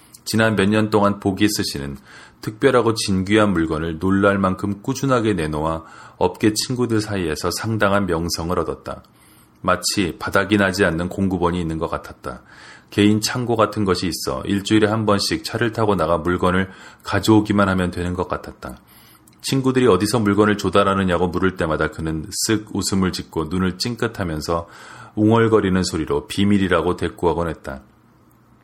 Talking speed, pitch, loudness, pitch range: 340 characters per minute, 100 Hz, -19 LUFS, 90-105 Hz